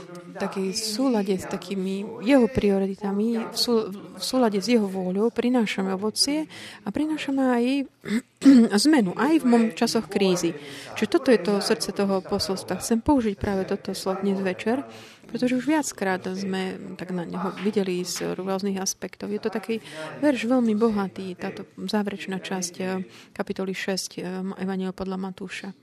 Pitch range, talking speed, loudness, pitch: 190-230 Hz, 140 wpm, -25 LUFS, 200 Hz